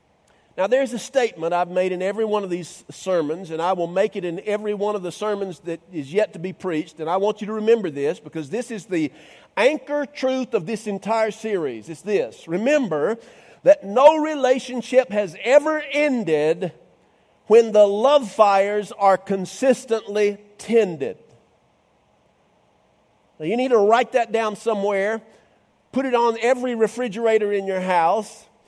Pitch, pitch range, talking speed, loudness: 210 Hz, 185-235 Hz, 165 wpm, -21 LUFS